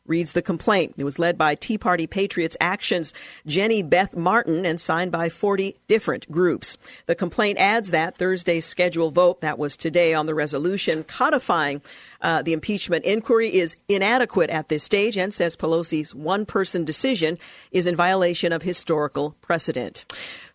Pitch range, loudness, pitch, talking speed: 160-195 Hz, -22 LUFS, 175 Hz, 160 wpm